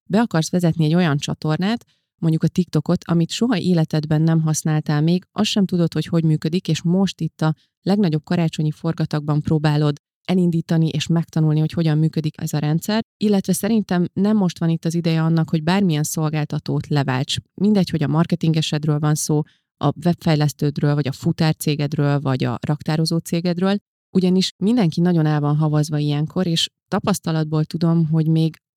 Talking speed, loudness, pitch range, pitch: 165 wpm, -20 LUFS, 155-175 Hz, 160 Hz